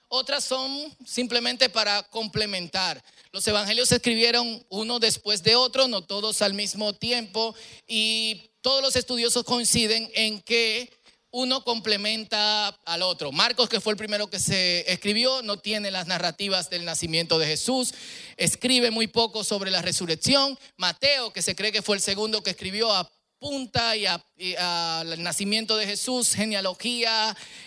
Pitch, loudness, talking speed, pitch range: 220 Hz, -23 LUFS, 150 wpm, 195-240 Hz